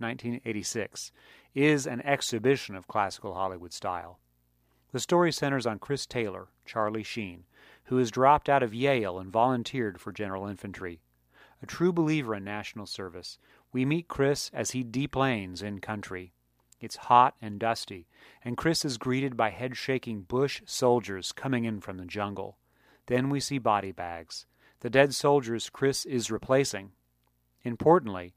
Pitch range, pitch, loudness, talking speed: 95-135 Hz, 115 Hz, -29 LUFS, 150 wpm